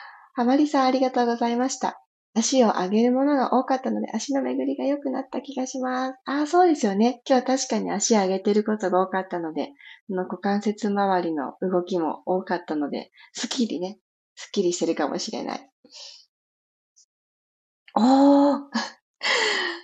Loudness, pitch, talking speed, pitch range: -23 LUFS, 240 Hz, 335 characters per minute, 190-265 Hz